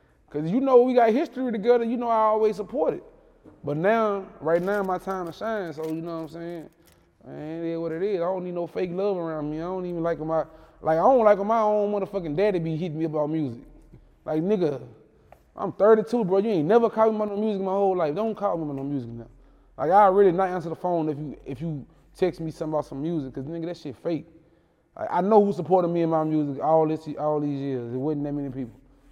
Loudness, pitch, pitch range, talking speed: -24 LUFS, 170 Hz, 155-205 Hz, 250 wpm